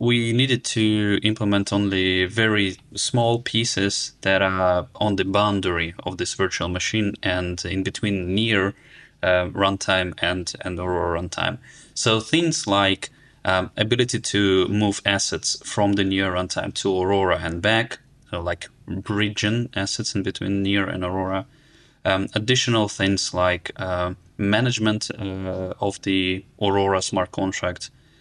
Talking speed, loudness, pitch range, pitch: 135 wpm, -22 LUFS, 95-110 Hz, 100 Hz